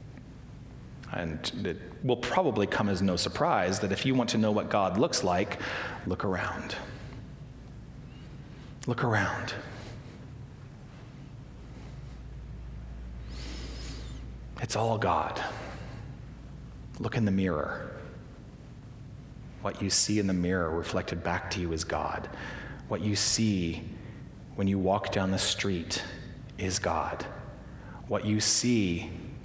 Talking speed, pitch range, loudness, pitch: 110 wpm, 90-125 Hz, -30 LUFS, 105 Hz